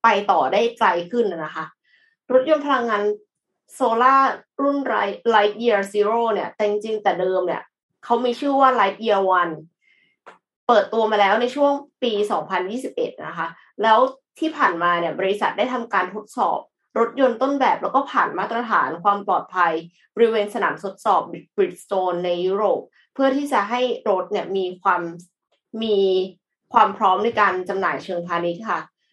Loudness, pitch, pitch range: -21 LUFS, 210 Hz, 185-250 Hz